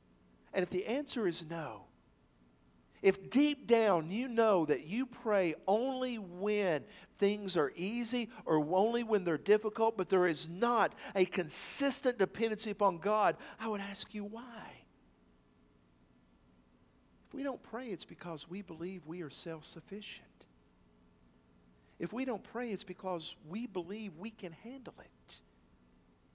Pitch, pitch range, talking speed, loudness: 190 Hz, 155-225 Hz, 140 wpm, -35 LUFS